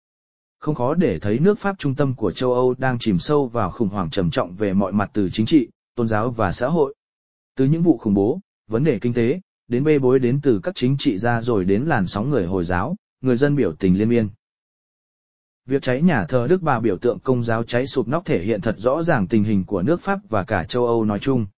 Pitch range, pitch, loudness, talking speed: 110-145 Hz, 125 Hz, -20 LUFS, 250 wpm